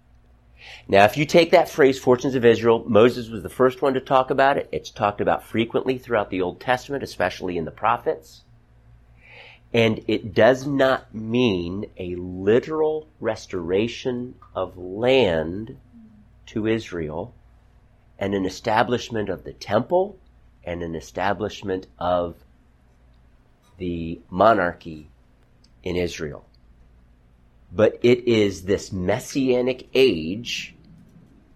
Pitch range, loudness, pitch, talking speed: 85-125 Hz, -22 LUFS, 105 Hz, 120 wpm